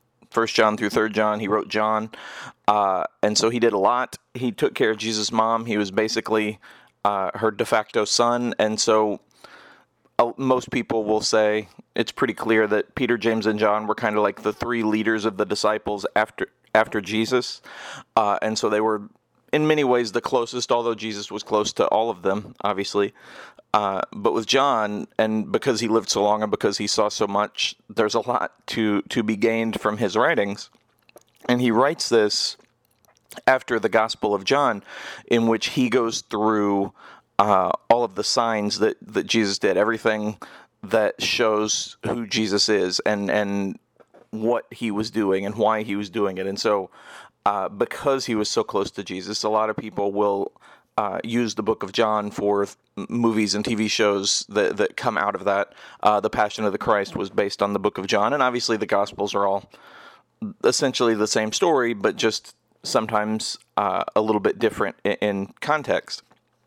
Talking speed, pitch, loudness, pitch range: 190 wpm, 110 Hz, -22 LUFS, 105-115 Hz